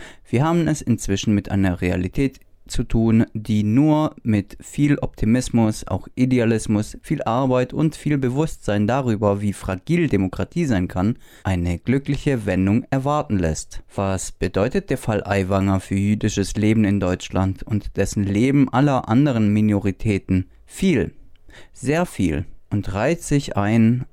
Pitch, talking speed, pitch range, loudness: 110 Hz, 135 wpm, 95-130 Hz, -21 LUFS